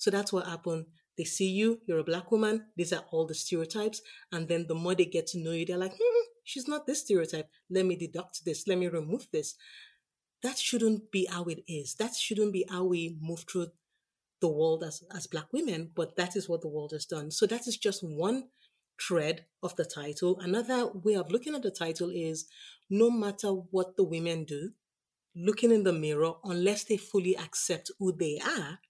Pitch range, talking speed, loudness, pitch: 165-215 Hz, 210 wpm, -32 LUFS, 180 Hz